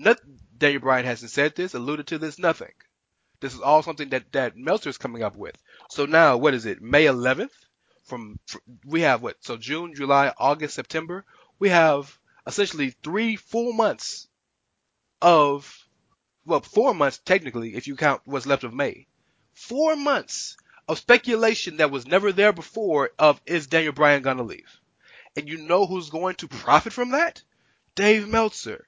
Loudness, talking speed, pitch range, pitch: -22 LUFS, 170 wpm, 140-195 Hz, 155 Hz